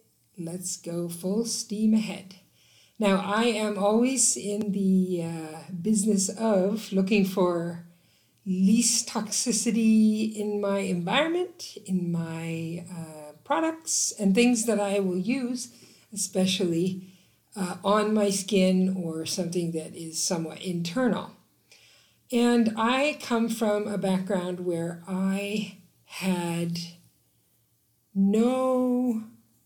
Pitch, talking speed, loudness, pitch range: 195 Hz, 105 wpm, -26 LUFS, 175-220 Hz